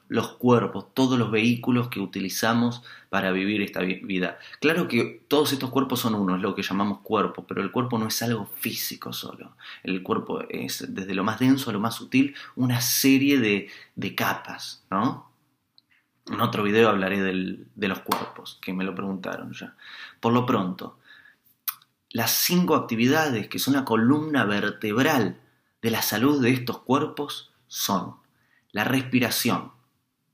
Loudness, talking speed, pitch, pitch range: -25 LUFS, 160 wpm, 115 Hz, 100-130 Hz